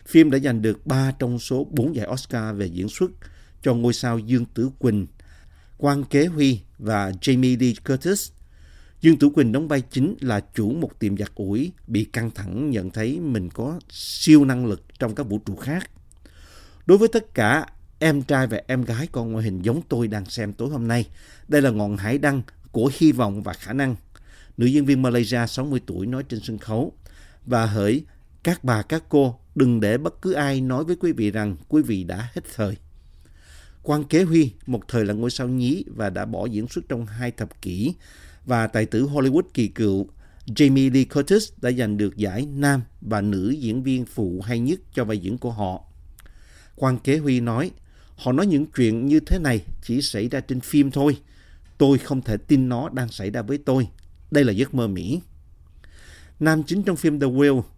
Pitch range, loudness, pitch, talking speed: 100-135 Hz, -22 LUFS, 120 Hz, 205 wpm